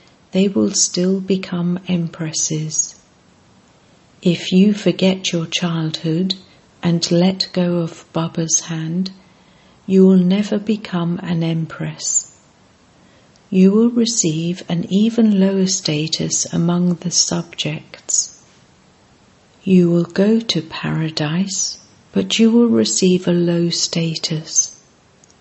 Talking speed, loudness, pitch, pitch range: 105 wpm, -17 LUFS, 175 Hz, 165-190 Hz